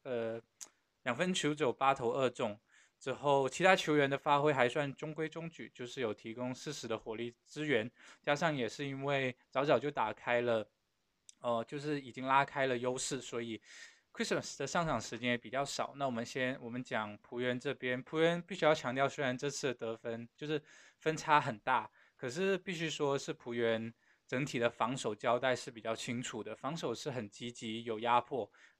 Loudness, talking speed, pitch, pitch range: -36 LUFS, 290 characters per minute, 130 Hz, 120-145 Hz